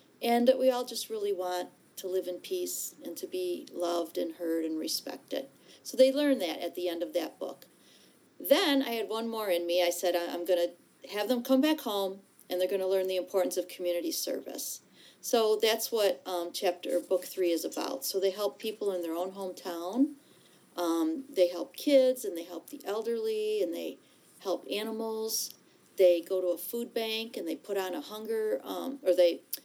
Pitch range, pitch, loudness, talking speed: 180-255 Hz, 195 Hz, -31 LUFS, 205 wpm